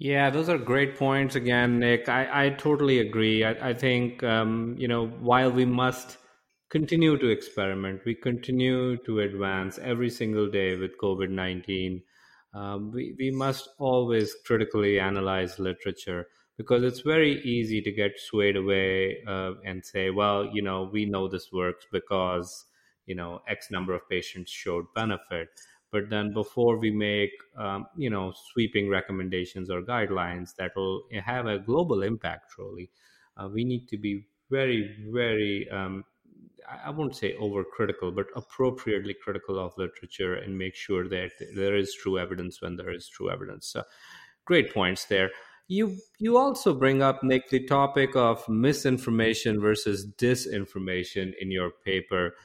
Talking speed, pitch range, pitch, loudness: 155 wpm, 95-125 Hz, 105 Hz, -28 LUFS